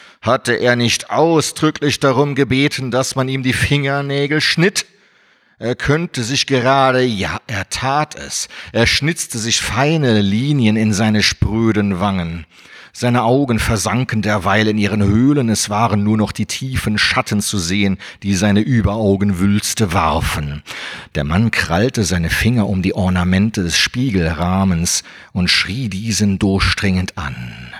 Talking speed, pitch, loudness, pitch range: 140 wpm, 110 Hz, -16 LUFS, 95-130 Hz